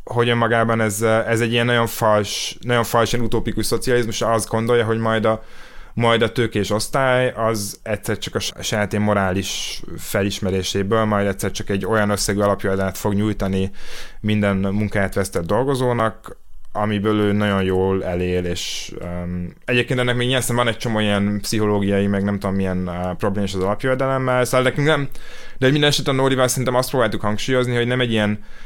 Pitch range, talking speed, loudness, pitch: 100-120 Hz, 170 wpm, -20 LUFS, 110 Hz